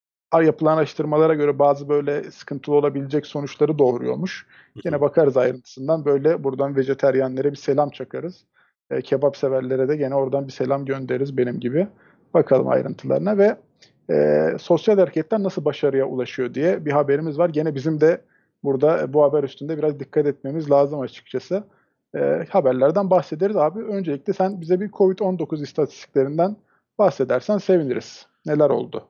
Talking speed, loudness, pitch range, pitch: 140 wpm, -21 LUFS, 135-170 Hz, 145 Hz